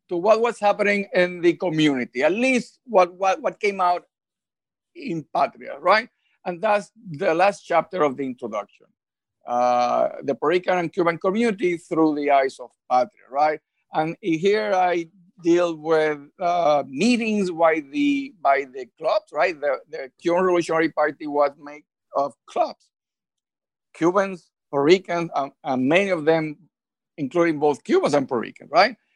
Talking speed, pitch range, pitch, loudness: 155 wpm, 150-200 Hz, 175 Hz, -22 LUFS